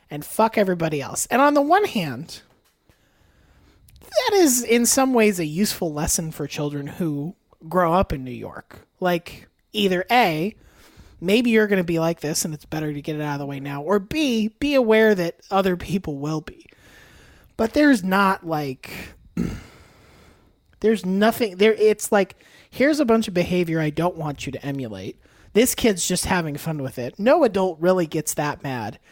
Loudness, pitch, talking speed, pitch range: -21 LUFS, 180 Hz, 180 wpm, 150-220 Hz